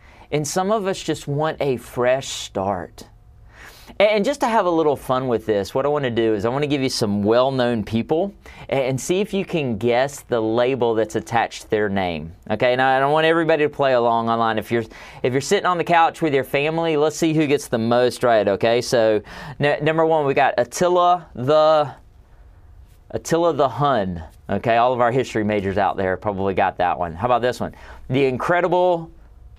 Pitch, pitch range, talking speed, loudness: 130 Hz, 110-155 Hz, 210 wpm, -20 LUFS